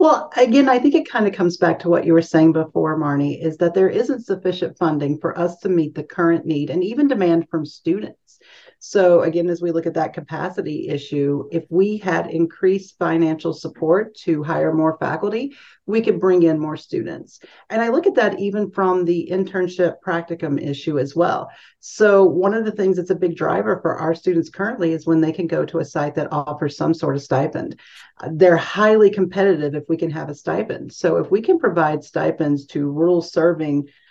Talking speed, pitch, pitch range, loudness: 205 wpm, 170 Hz, 160-190 Hz, -19 LUFS